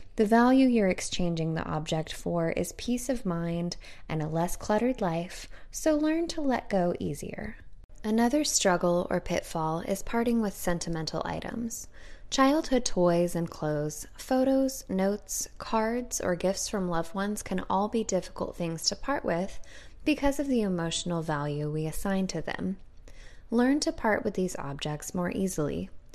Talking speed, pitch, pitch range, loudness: 155 wpm, 190 Hz, 170-235 Hz, -29 LUFS